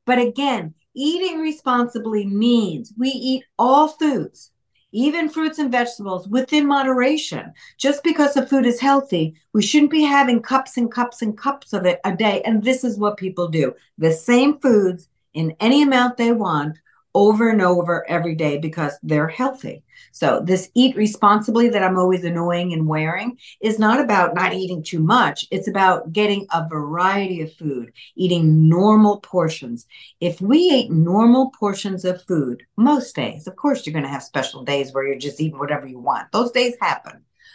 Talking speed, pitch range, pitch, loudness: 175 wpm, 170-255 Hz, 210 Hz, -19 LUFS